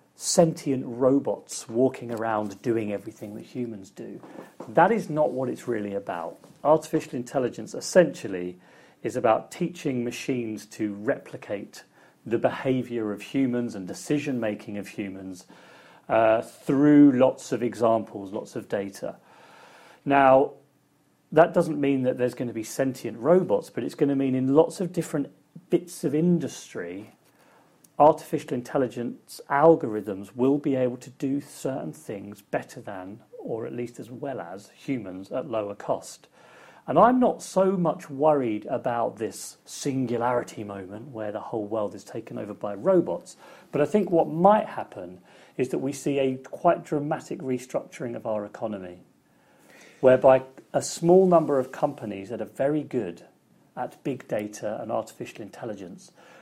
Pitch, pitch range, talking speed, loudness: 130 Hz, 110-150 Hz, 150 wpm, -25 LUFS